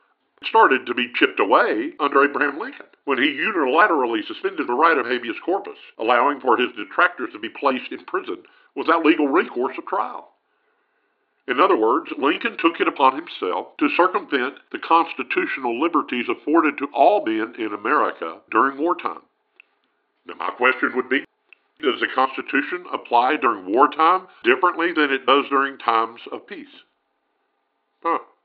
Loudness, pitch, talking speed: -20 LUFS, 325 Hz, 150 wpm